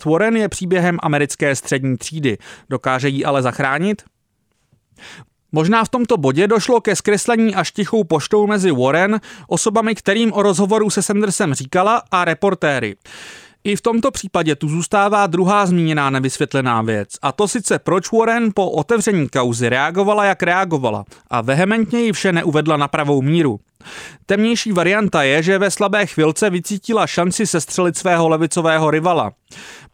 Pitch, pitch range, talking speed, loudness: 180 Hz, 145-210 Hz, 145 wpm, -16 LUFS